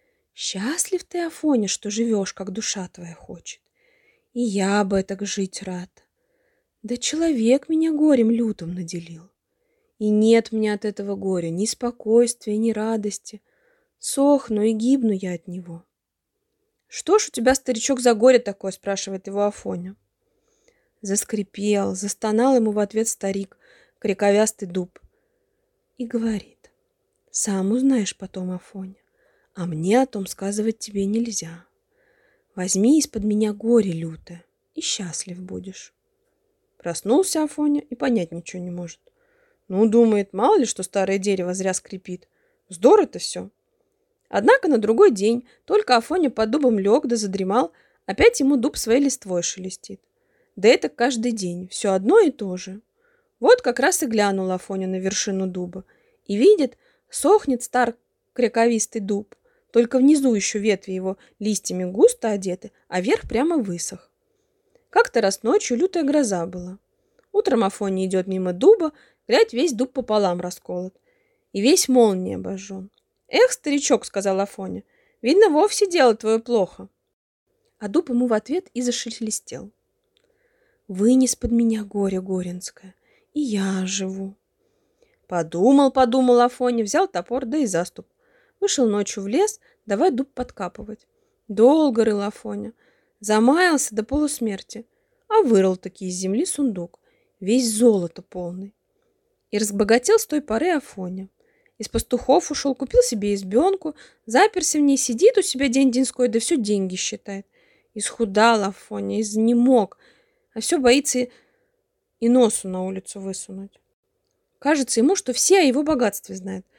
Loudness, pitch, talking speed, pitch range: -21 LUFS, 235 Hz, 135 wpm, 195-330 Hz